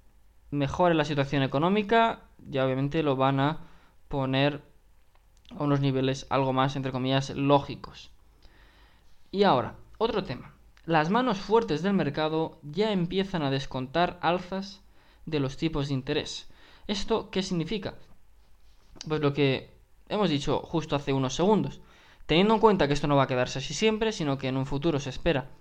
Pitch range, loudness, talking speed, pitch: 135-175 Hz, -27 LUFS, 155 wpm, 145 Hz